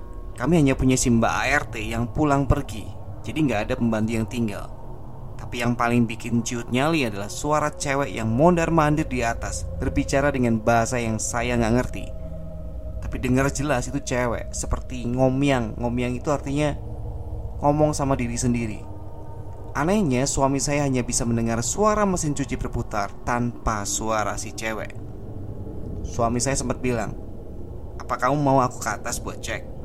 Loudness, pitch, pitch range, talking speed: -23 LUFS, 120 Hz, 110-135 Hz, 150 wpm